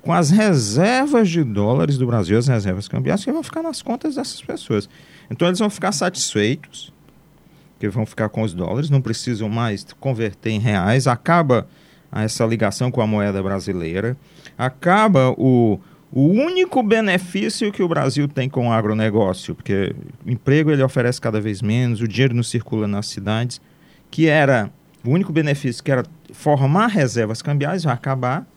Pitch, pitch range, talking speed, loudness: 130 Hz, 115-175 Hz, 165 wpm, -19 LUFS